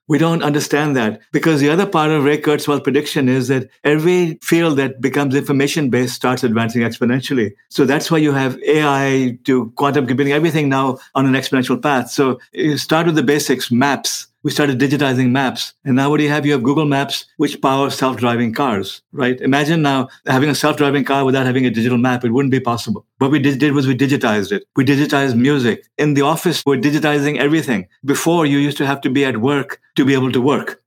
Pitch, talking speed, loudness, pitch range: 140 Hz, 215 wpm, -16 LUFS, 130-150 Hz